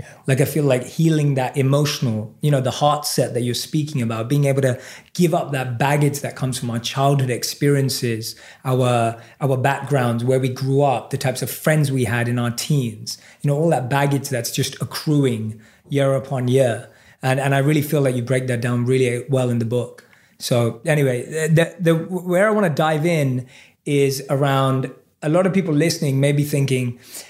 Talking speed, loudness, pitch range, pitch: 200 wpm, -20 LUFS, 125-145 Hz, 135 Hz